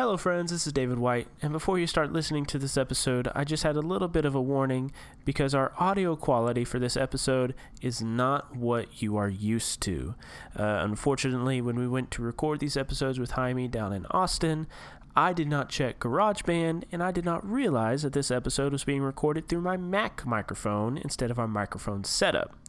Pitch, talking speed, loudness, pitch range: 135 Hz, 200 wpm, -29 LUFS, 125-155 Hz